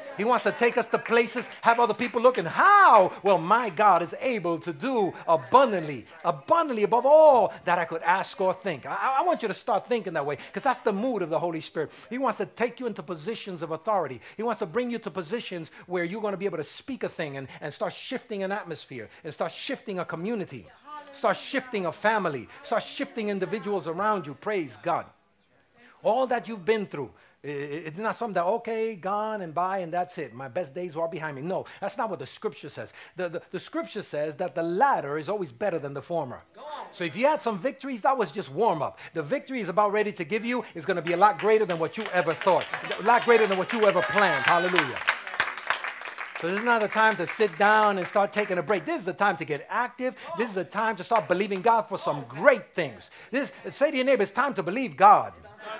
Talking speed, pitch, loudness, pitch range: 240 wpm, 210 Hz, -26 LUFS, 180-235 Hz